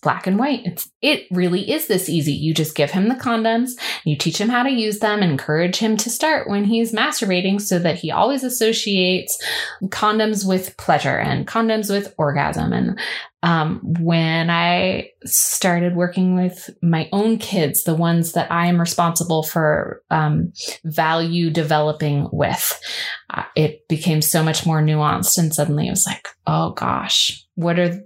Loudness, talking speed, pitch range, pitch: -19 LUFS, 170 wpm, 160-210 Hz, 180 Hz